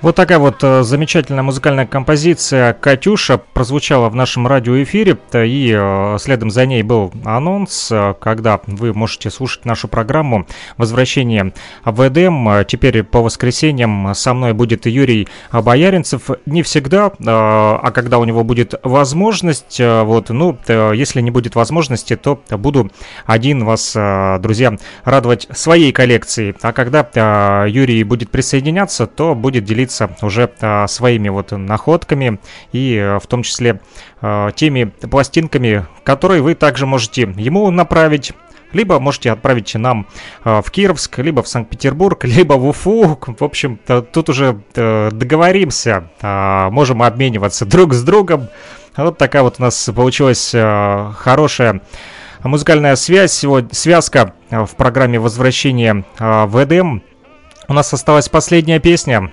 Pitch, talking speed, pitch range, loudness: 125 Hz, 130 wpm, 110-145 Hz, -13 LUFS